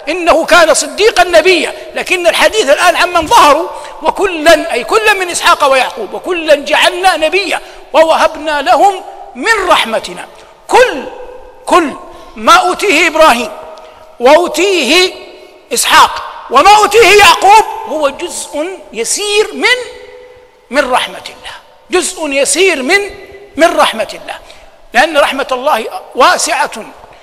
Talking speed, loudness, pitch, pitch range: 110 wpm, -9 LUFS, 345 Hz, 310-400 Hz